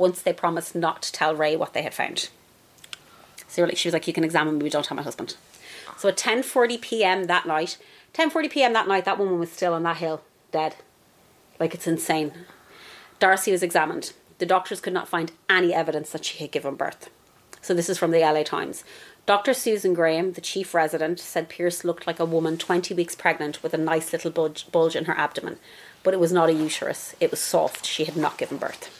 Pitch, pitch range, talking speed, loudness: 170 Hz, 160-185 Hz, 215 wpm, -24 LUFS